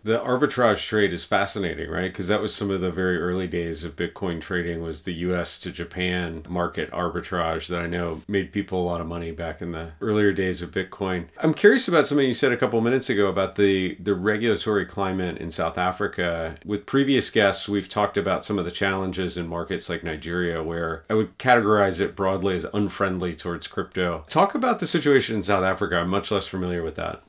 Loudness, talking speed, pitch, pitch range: -24 LUFS, 215 wpm, 95 Hz, 85-105 Hz